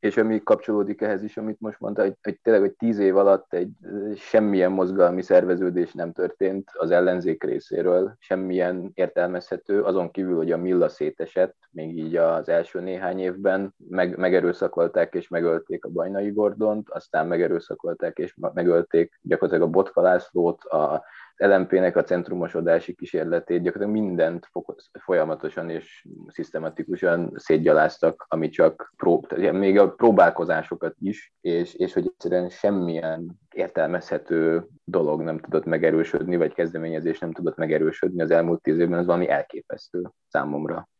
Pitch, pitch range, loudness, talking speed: 90 Hz, 85-100 Hz, -23 LUFS, 140 wpm